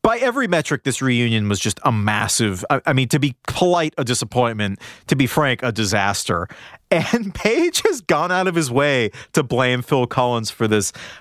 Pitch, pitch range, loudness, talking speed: 130 Hz, 115-155 Hz, -19 LUFS, 195 wpm